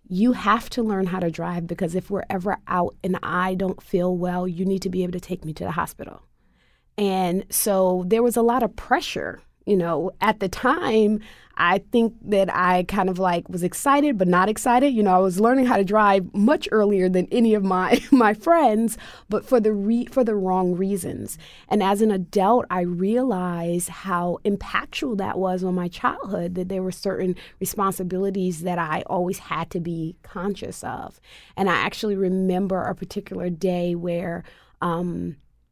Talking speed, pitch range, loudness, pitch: 190 wpm, 180-210 Hz, -22 LUFS, 190 Hz